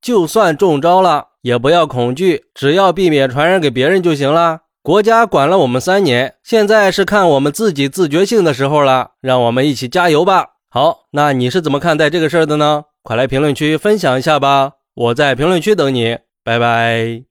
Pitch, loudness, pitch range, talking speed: 150 Hz, -13 LUFS, 130-185 Hz, 300 characters per minute